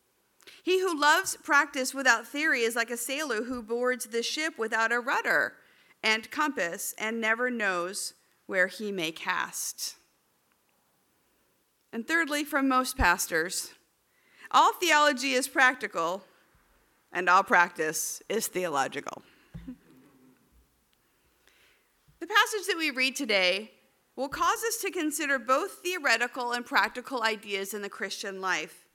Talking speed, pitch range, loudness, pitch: 125 wpm, 205-295 Hz, -27 LUFS, 250 Hz